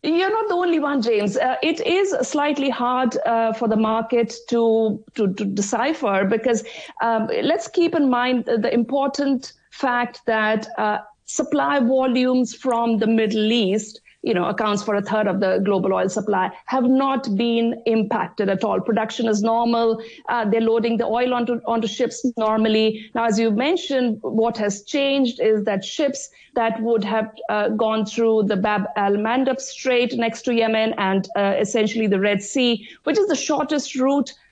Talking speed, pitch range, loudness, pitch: 175 wpm, 220-255 Hz, -21 LUFS, 230 Hz